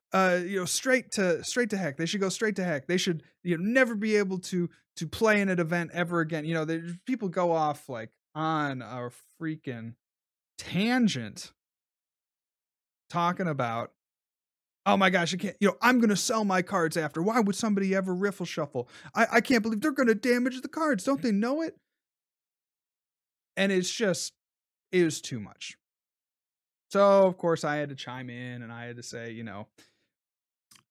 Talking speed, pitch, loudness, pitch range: 185 wpm, 175 Hz, -27 LUFS, 150-205 Hz